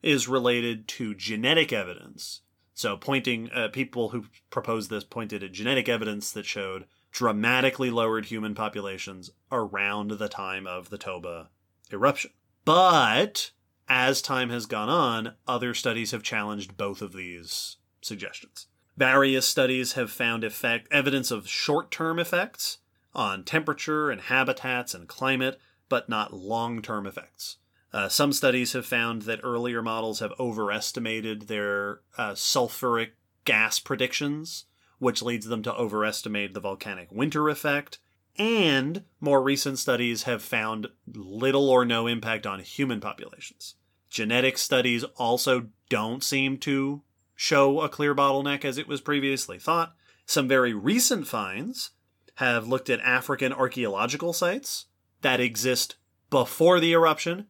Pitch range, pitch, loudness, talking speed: 105-135 Hz, 120 Hz, -26 LUFS, 135 wpm